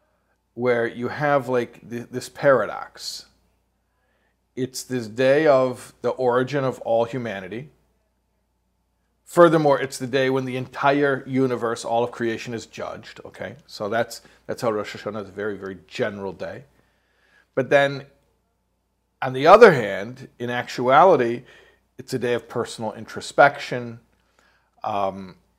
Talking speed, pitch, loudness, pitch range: 135 wpm, 120 Hz, -21 LUFS, 110-130 Hz